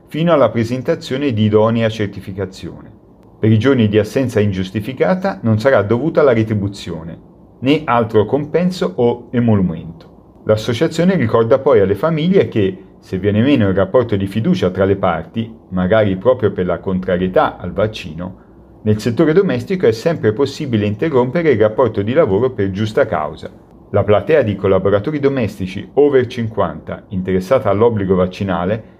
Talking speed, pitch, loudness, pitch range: 145 wpm, 110 Hz, -15 LUFS, 95-130 Hz